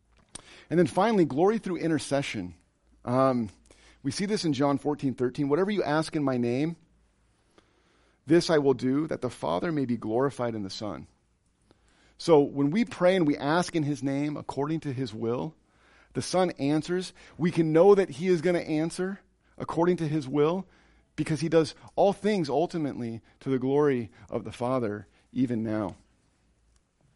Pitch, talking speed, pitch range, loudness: 145 Hz, 170 wpm, 125-170 Hz, -27 LUFS